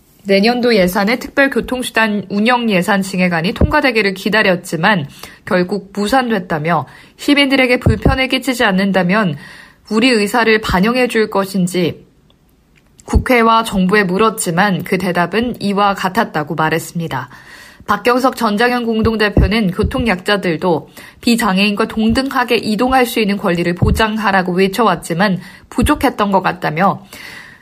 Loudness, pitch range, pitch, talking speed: -14 LUFS, 185-235 Hz, 210 Hz, 310 characters per minute